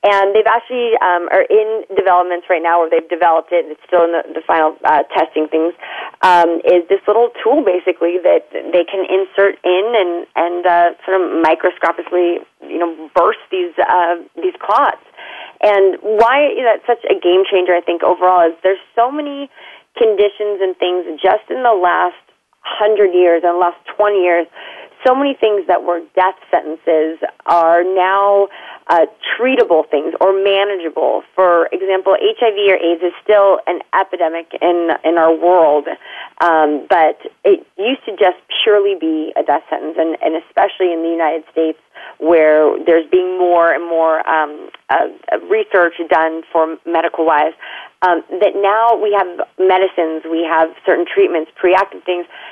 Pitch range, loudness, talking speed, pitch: 165-200 Hz, -14 LUFS, 165 wpm, 180 Hz